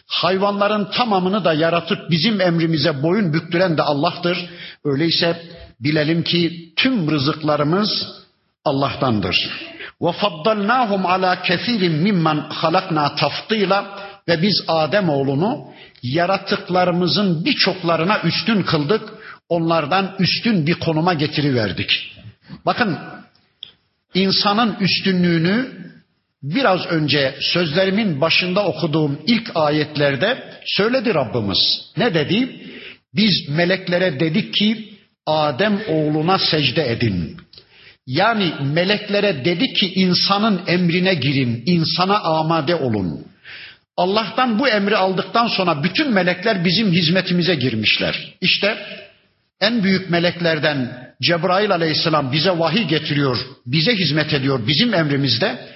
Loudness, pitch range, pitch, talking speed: -18 LUFS, 155-200 Hz, 175 Hz, 100 wpm